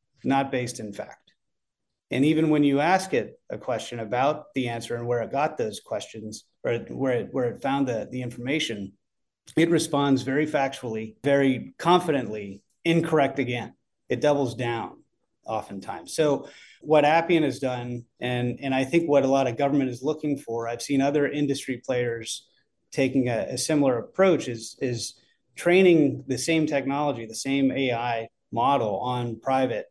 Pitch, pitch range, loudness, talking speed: 135 Hz, 120-145 Hz, -25 LUFS, 165 wpm